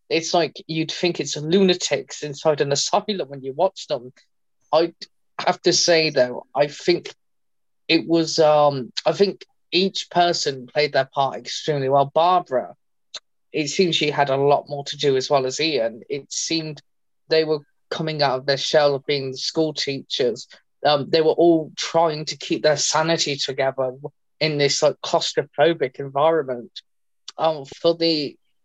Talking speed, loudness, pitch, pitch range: 165 wpm, -21 LUFS, 150 Hz, 140-165 Hz